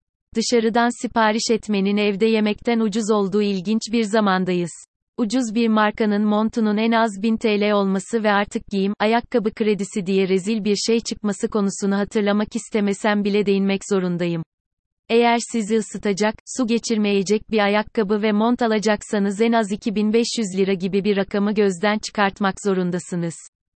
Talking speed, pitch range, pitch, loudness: 140 wpm, 200-225 Hz, 210 Hz, -20 LUFS